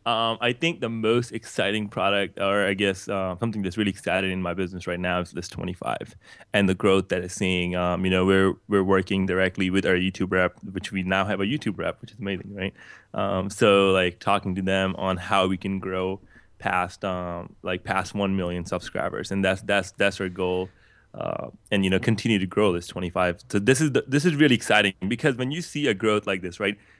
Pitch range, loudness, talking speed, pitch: 95-100 Hz, -24 LUFS, 225 wpm, 95 Hz